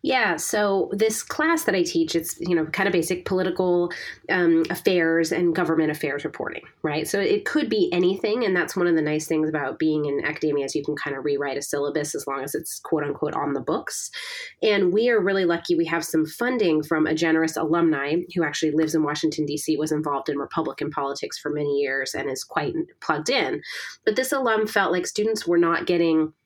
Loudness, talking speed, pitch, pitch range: -23 LUFS, 220 wpm, 165 Hz, 155-185 Hz